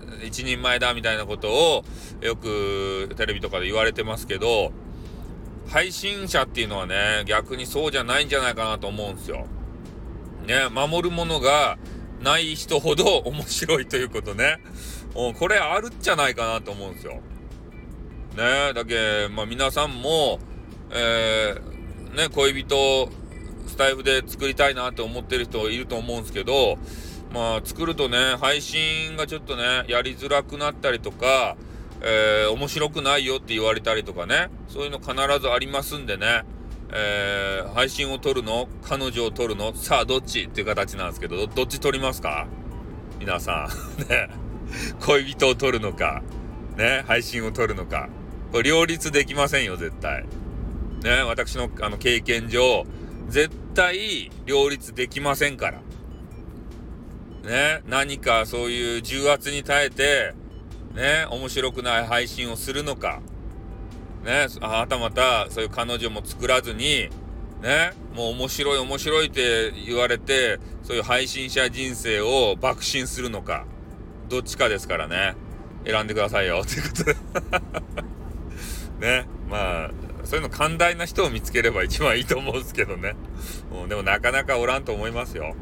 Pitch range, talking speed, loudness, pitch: 105-140 Hz, 300 characters per minute, -23 LUFS, 120 Hz